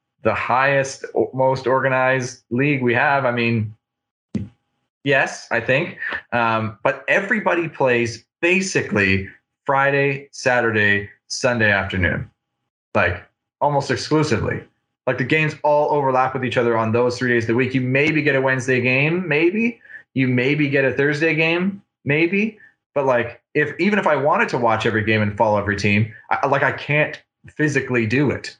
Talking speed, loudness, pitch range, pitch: 155 wpm, -19 LUFS, 115-150 Hz, 130 Hz